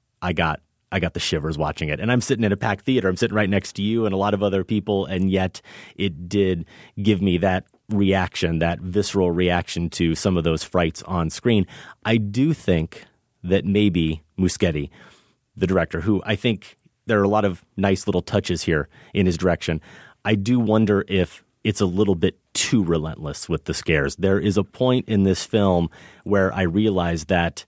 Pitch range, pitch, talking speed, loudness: 85-105 Hz, 95 Hz, 200 wpm, -22 LUFS